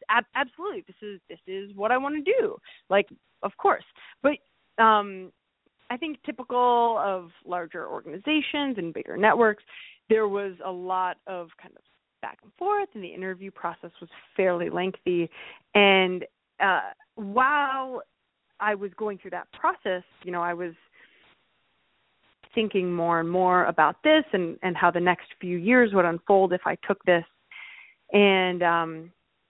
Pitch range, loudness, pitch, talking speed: 180-245 Hz, -25 LUFS, 195 Hz, 155 wpm